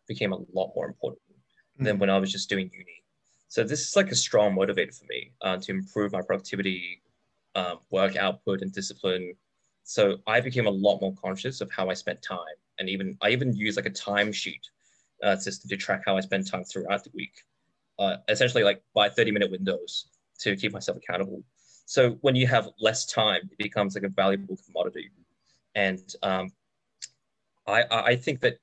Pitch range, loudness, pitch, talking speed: 95-115 Hz, -27 LUFS, 100 Hz, 190 wpm